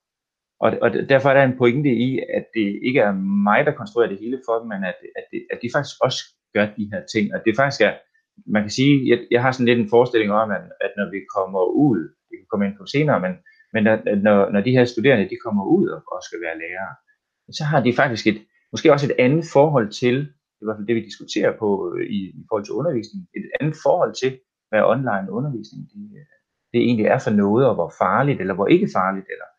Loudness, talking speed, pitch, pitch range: -20 LUFS, 235 wpm, 120 Hz, 105-150 Hz